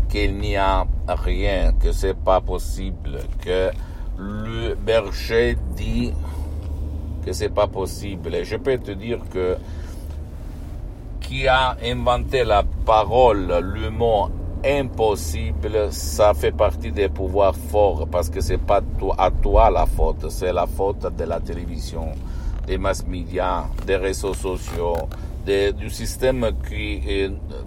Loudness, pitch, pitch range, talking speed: -22 LUFS, 90 Hz, 80-100 Hz, 130 wpm